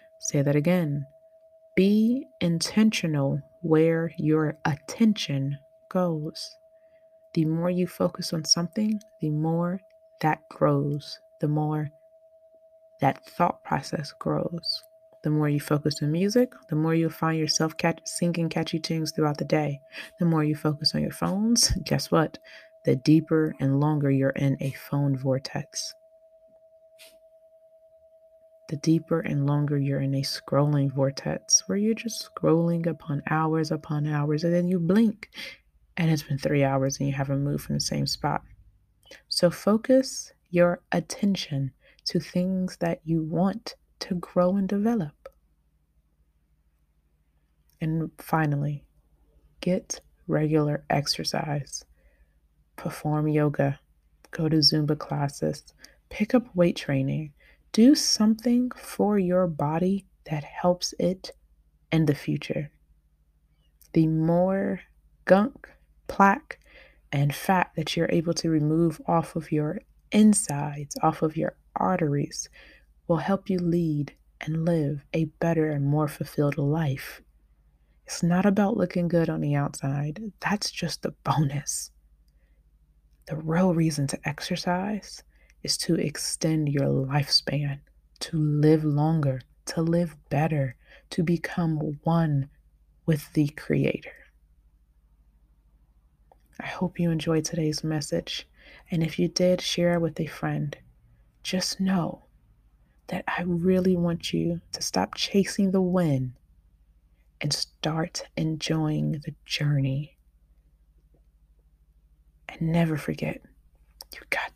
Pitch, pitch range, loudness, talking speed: 160 Hz, 140-180 Hz, -26 LUFS, 125 wpm